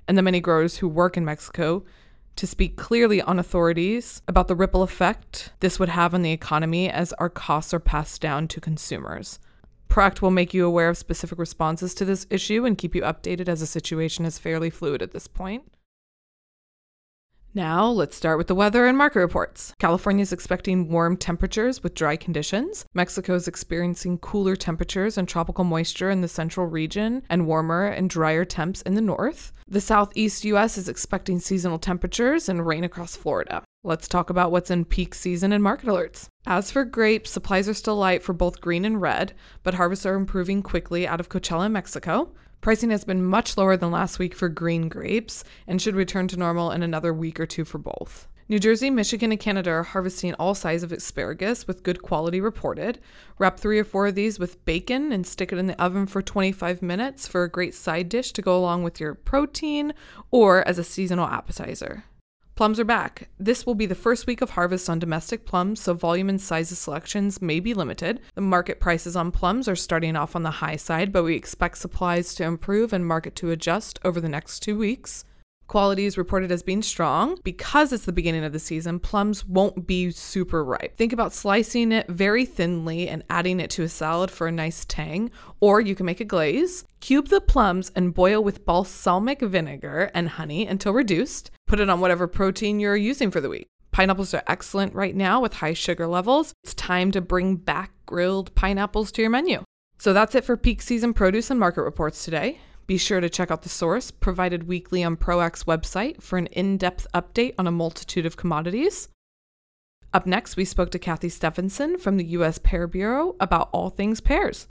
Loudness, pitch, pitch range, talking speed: -24 LUFS, 185 Hz, 170-205 Hz, 200 wpm